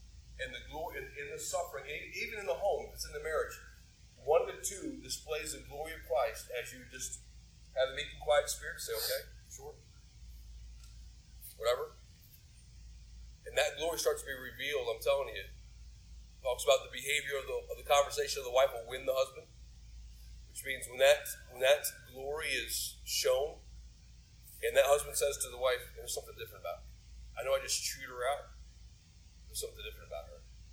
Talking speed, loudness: 185 wpm, -35 LUFS